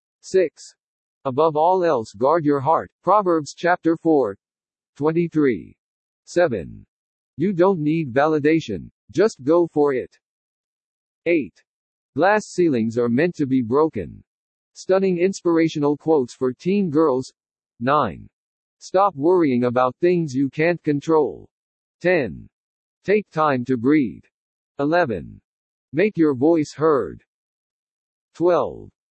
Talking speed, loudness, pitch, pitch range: 110 wpm, -20 LUFS, 160 Hz, 145-175 Hz